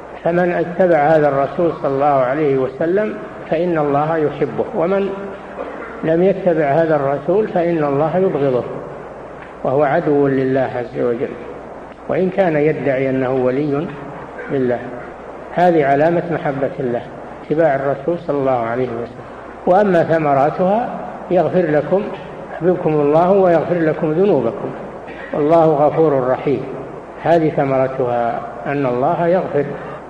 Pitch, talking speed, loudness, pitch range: 155 Hz, 115 wpm, -17 LUFS, 140-175 Hz